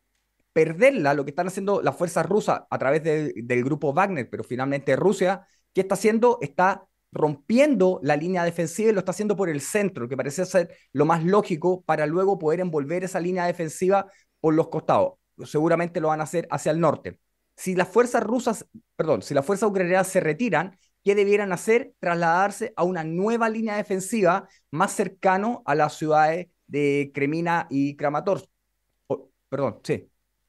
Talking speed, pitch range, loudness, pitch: 175 wpm, 155-200 Hz, -24 LUFS, 180 Hz